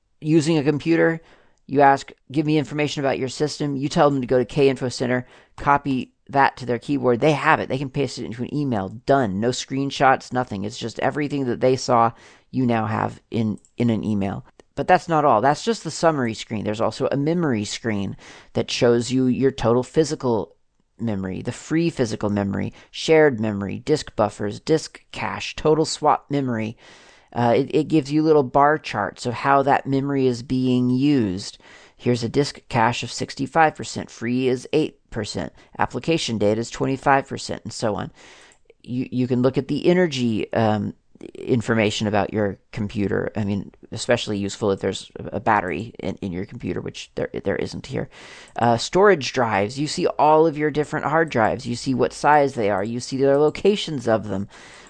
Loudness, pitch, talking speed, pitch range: -22 LUFS, 130 Hz, 185 wpm, 115-145 Hz